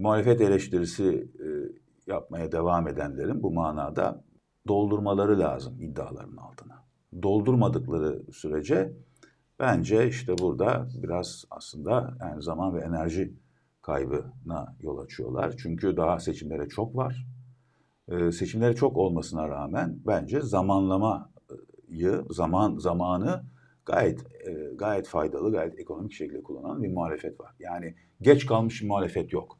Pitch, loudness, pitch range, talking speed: 95 Hz, -28 LUFS, 85-120 Hz, 120 wpm